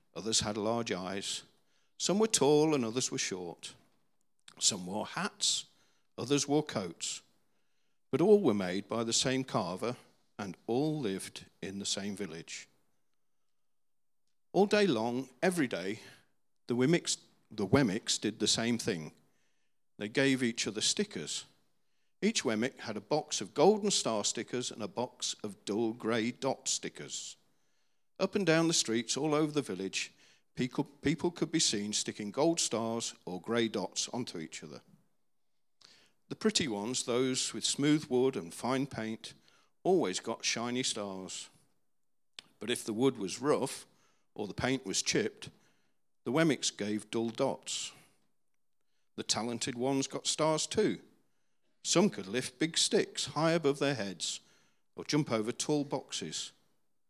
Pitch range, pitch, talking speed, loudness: 110-150 Hz, 125 Hz, 145 wpm, -32 LUFS